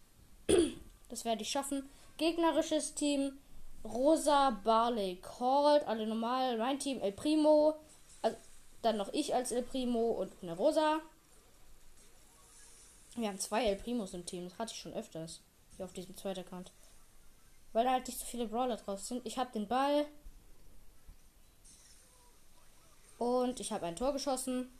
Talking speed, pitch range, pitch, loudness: 150 wpm, 215-280 Hz, 245 Hz, -34 LUFS